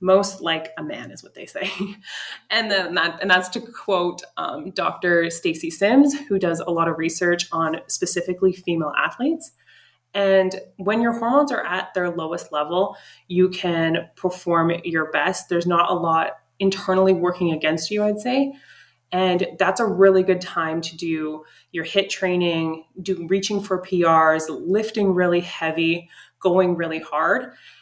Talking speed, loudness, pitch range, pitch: 160 wpm, -21 LUFS, 165-195 Hz, 180 Hz